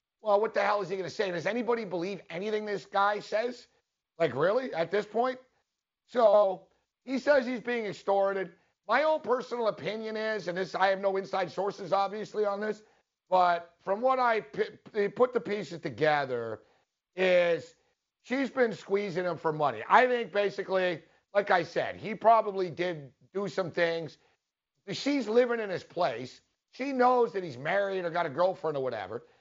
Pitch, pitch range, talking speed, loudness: 200 Hz, 180-230 Hz, 175 wpm, -29 LUFS